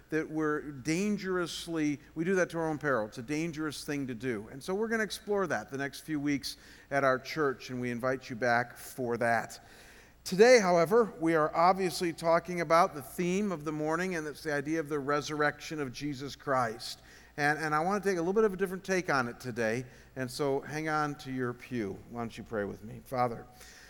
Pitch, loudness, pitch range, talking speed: 150 Hz, -31 LUFS, 130-170 Hz, 225 wpm